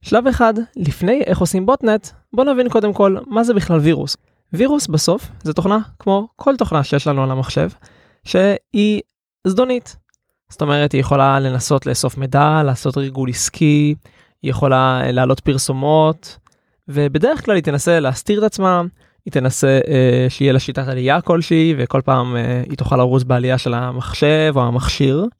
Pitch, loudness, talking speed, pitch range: 150 Hz, -16 LUFS, 160 wpm, 135-195 Hz